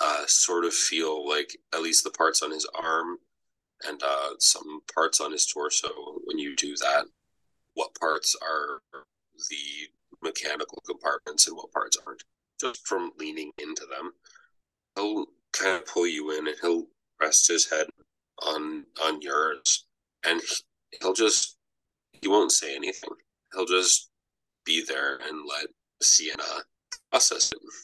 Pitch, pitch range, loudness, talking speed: 385 Hz, 330-440 Hz, -25 LUFS, 145 wpm